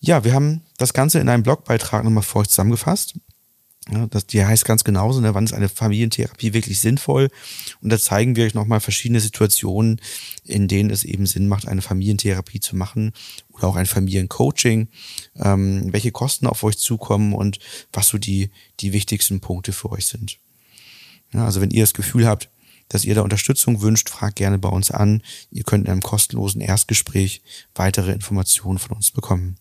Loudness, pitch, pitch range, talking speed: -19 LUFS, 105 Hz, 100-115 Hz, 185 wpm